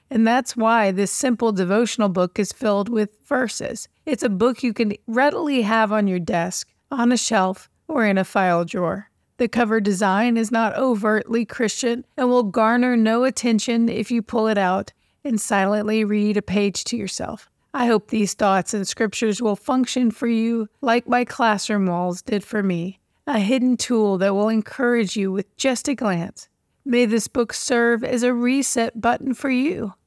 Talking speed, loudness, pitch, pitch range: 180 wpm, -21 LUFS, 225 Hz, 205-245 Hz